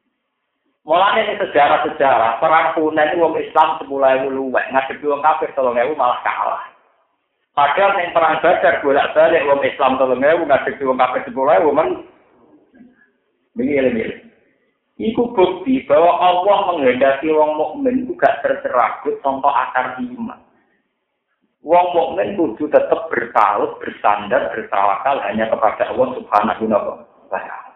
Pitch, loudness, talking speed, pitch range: 160 Hz, -16 LUFS, 125 wpm, 145-210 Hz